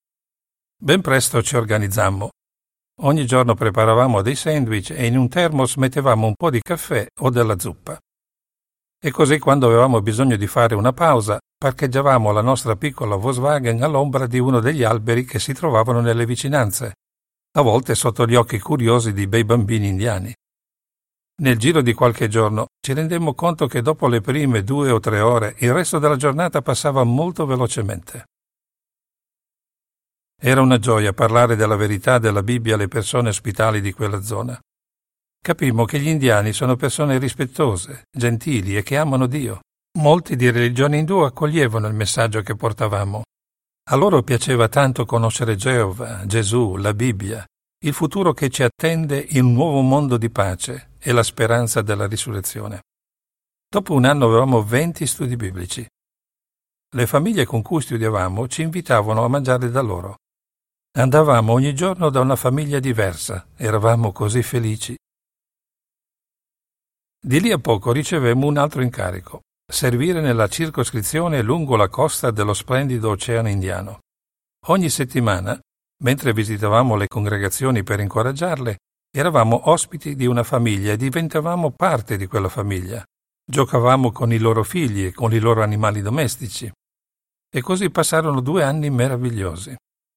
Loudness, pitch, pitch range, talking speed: -18 LUFS, 120 Hz, 110-140 Hz, 145 wpm